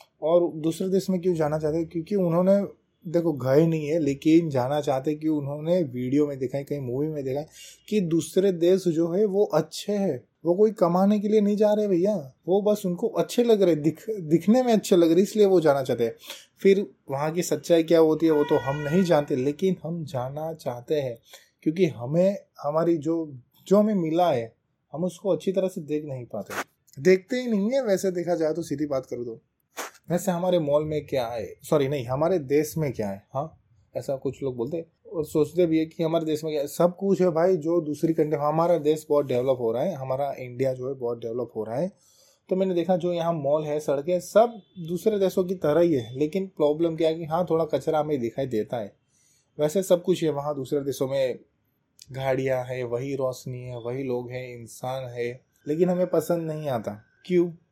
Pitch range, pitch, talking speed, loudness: 140-180 Hz, 160 Hz, 220 wpm, -25 LUFS